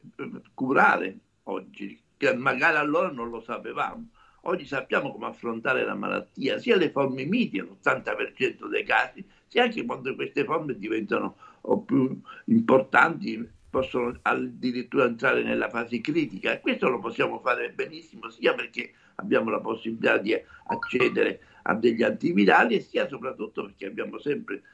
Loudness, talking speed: -26 LUFS, 135 wpm